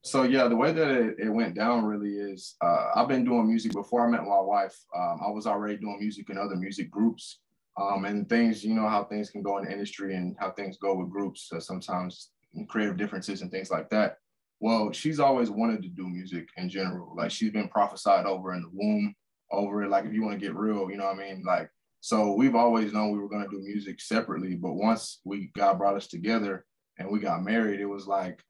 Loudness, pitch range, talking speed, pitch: -28 LUFS, 95-115 Hz, 240 wpm, 100 Hz